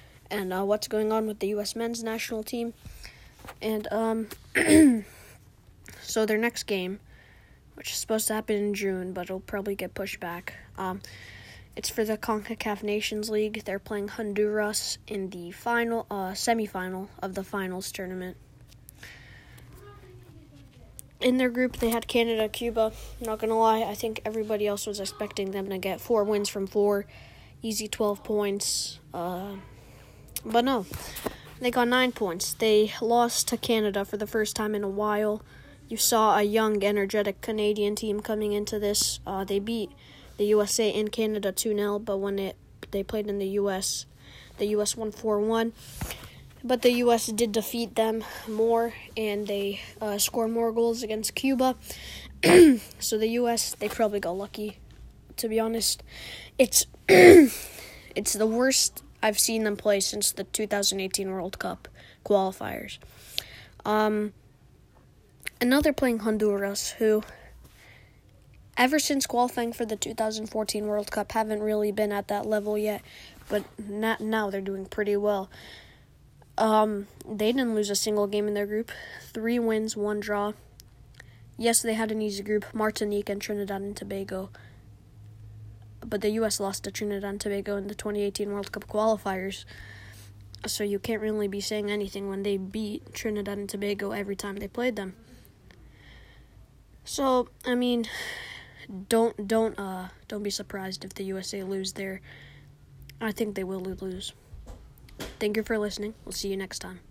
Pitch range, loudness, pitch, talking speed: 195-220 Hz, -27 LUFS, 210 Hz, 155 wpm